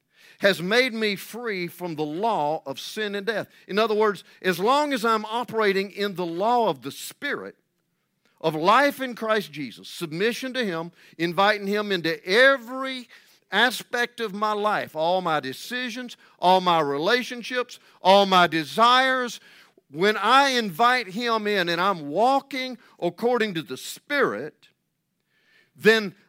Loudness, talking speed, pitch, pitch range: -23 LUFS, 145 wpm, 210 Hz, 175-240 Hz